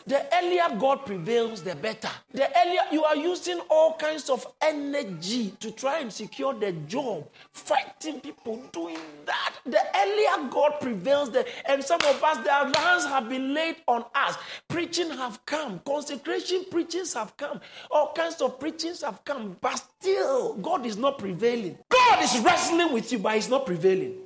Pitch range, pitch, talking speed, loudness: 235-330 Hz, 280 Hz, 170 wpm, -26 LUFS